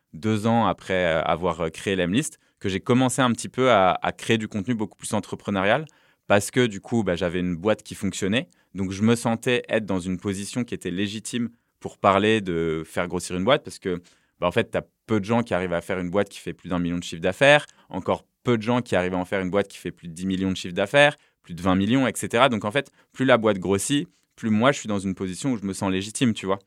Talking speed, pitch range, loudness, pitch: 270 wpm, 90-115 Hz, -24 LUFS, 100 Hz